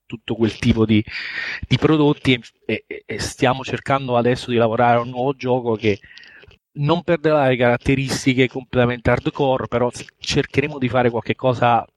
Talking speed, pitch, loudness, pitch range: 155 wpm, 125 Hz, -19 LUFS, 120-135 Hz